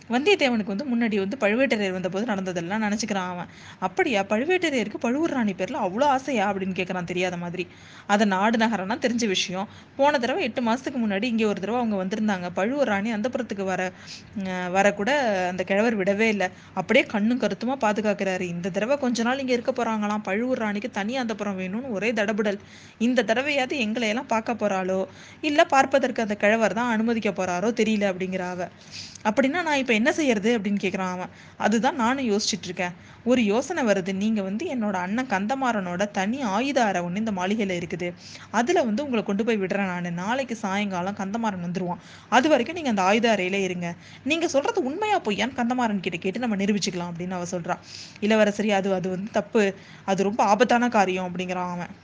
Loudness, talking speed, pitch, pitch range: -24 LUFS, 175 wpm, 210 Hz, 190-240 Hz